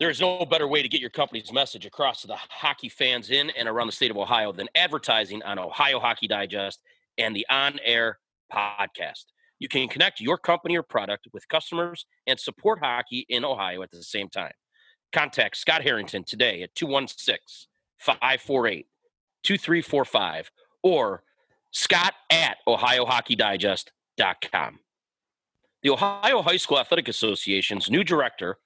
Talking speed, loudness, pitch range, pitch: 150 wpm, -24 LUFS, 115-180 Hz, 145 Hz